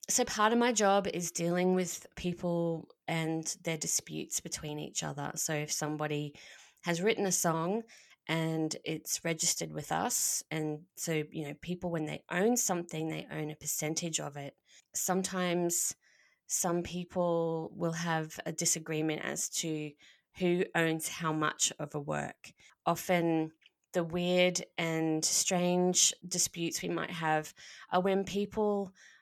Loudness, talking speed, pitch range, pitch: -32 LUFS, 145 wpm, 155-180 Hz, 170 Hz